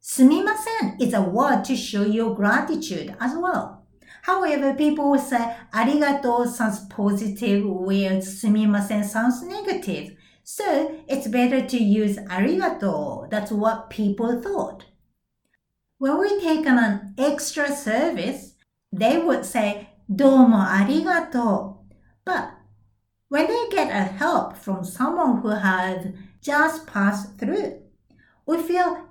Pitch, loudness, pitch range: 240 Hz, -22 LUFS, 205-295 Hz